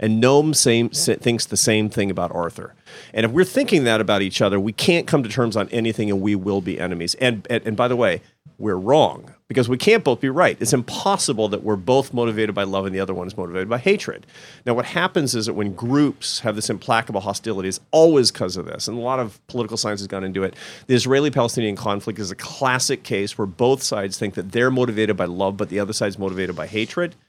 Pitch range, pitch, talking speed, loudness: 100-130 Hz, 115 Hz, 240 wpm, -20 LUFS